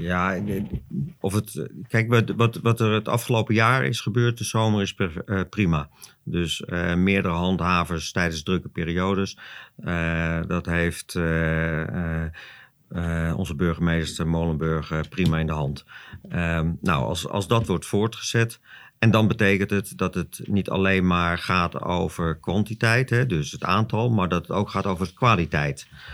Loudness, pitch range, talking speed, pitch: -24 LUFS, 85-105 Hz, 150 wpm, 90 Hz